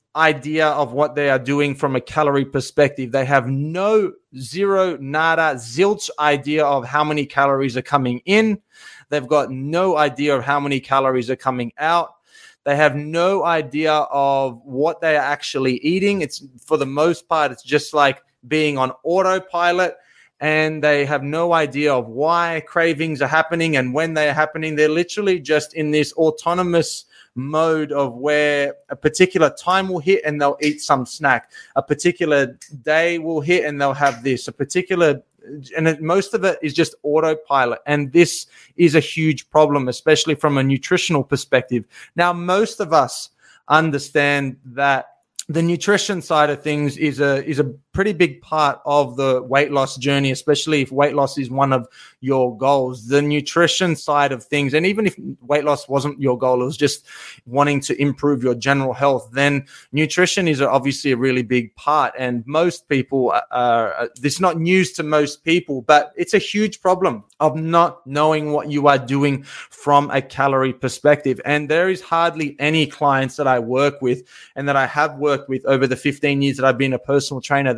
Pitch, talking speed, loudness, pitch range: 145 Hz, 180 wpm, -18 LUFS, 135-160 Hz